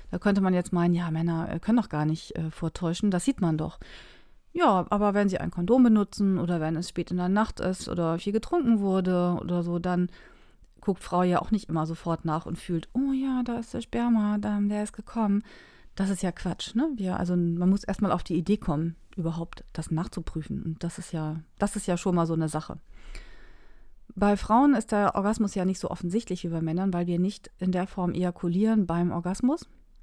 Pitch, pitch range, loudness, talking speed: 180 Hz, 170-210 Hz, -27 LUFS, 215 wpm